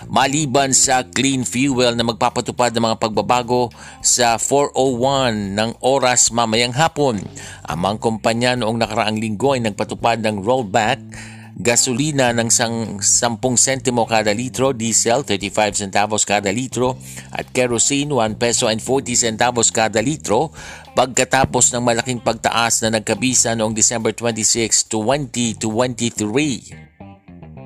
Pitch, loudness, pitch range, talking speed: 115 Hz, -17 LUFS, 110-125 Hz, 120 wpm